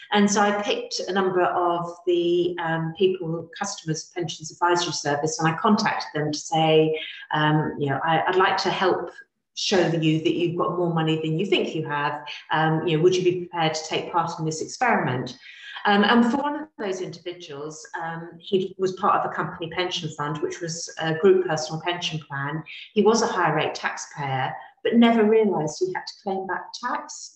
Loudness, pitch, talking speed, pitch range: -23 LUFS, 175 Hz, 200 wpm, 160-200 Hz